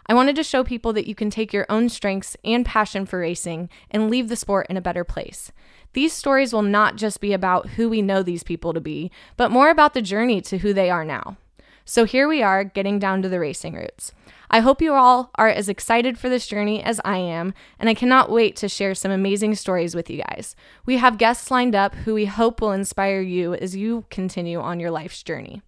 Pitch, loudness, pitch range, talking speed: 210 Hz, -20 LUFS, 190-235 Hz, 235 wpm